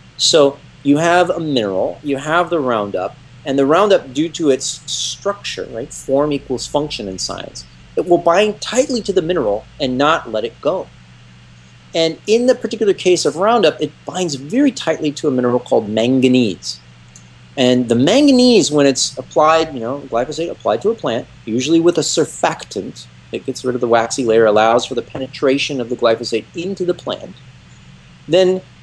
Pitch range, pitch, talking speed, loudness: 120-175 Hz, 140 Hz, 175 wpm, -16 LUFS